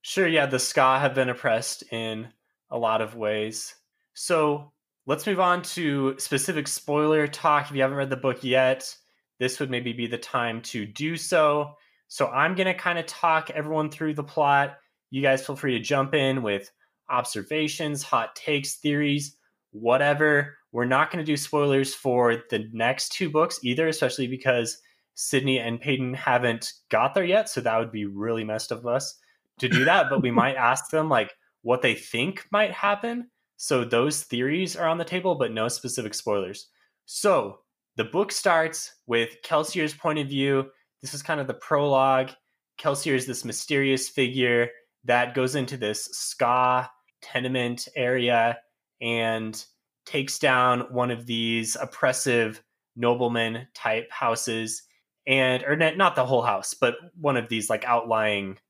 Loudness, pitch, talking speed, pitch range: -25 LUFS, 130 Hz, 165 wpm, 120-150 Hz